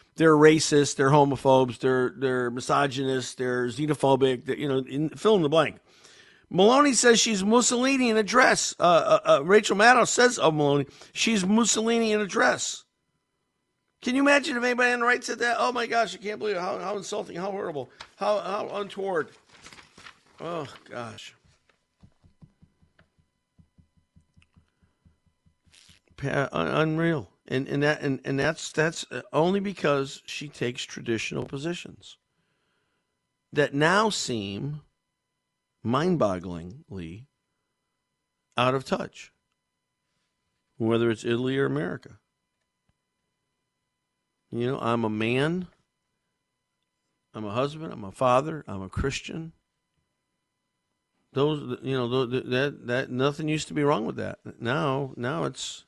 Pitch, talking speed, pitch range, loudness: 145 Hz, 130 wpm, 125-200 Hz, -25 LUFS